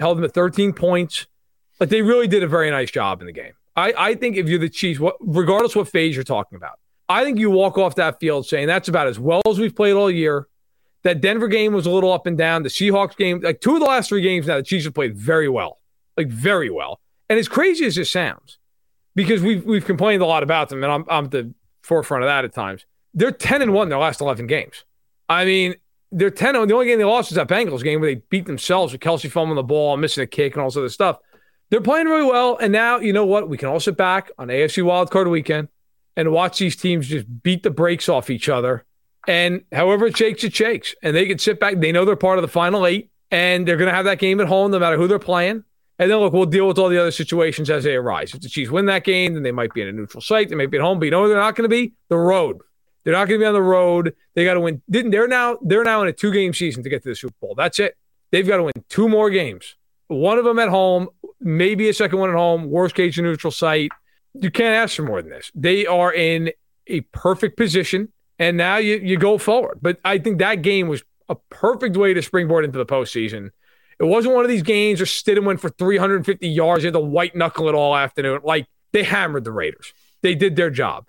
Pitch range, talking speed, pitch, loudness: 160-205 Hz, 270 wpm, 180 Hz, -18 LUFS